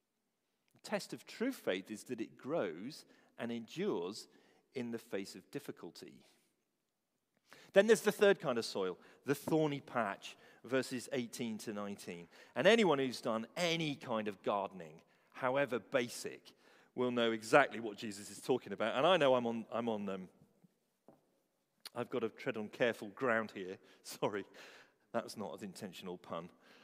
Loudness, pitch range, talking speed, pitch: -37 LUFS, 105-135 Hz, 155 wpm, 115 Hz